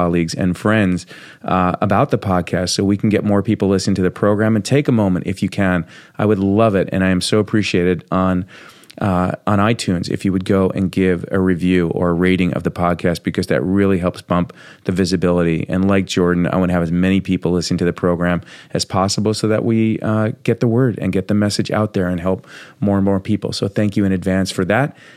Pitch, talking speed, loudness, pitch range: 95 Hz, 240 wpm, -17 LUFS, 90-105 Hz